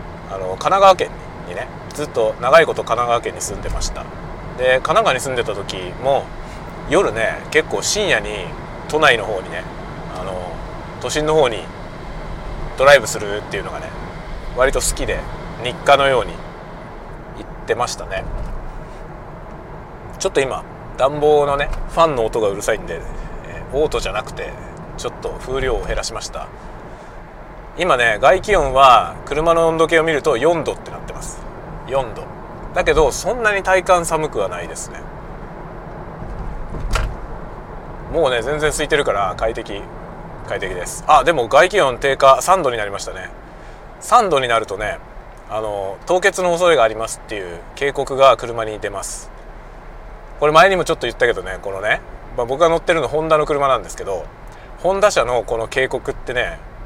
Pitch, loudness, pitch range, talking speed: 145 Hz, -17 LUFS, 115-165 Hz, 300 characters per minute